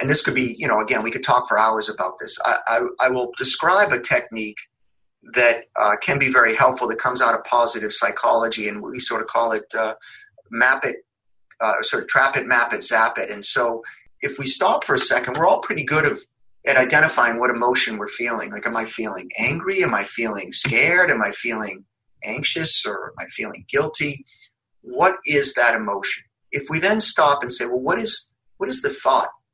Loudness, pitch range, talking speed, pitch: -19 LUFS, 115-190 Hz, 215 wpm, 130 Hz